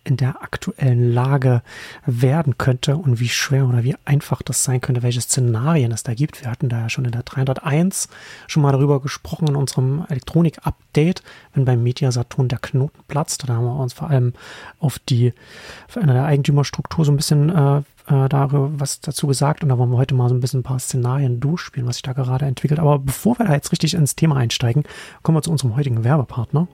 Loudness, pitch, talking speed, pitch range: -19 LUFS, 135 Hz, 210 wpm, 125-150 Hz